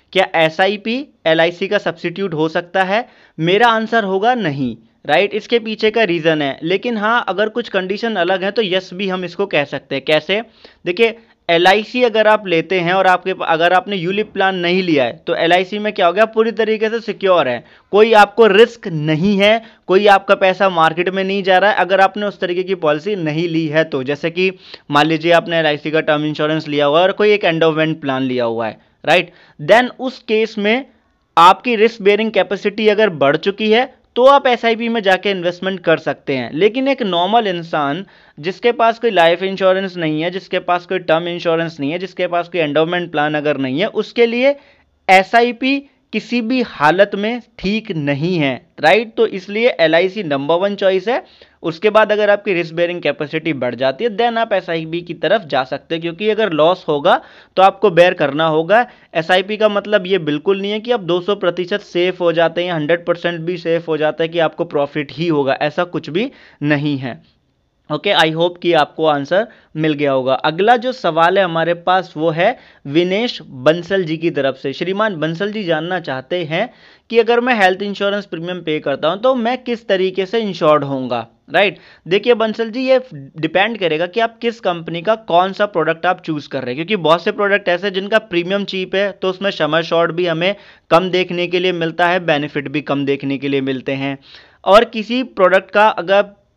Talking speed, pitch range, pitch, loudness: 210 wpm, 160-210 Hz, 185 Hz, -16 LUFS